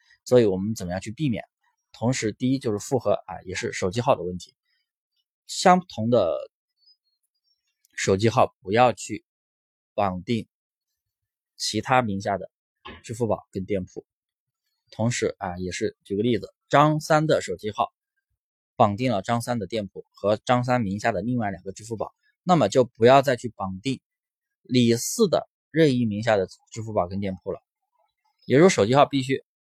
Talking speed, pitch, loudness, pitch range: 235 characters per minute, 115 Hz, -24 LUFS, 100-135 Hz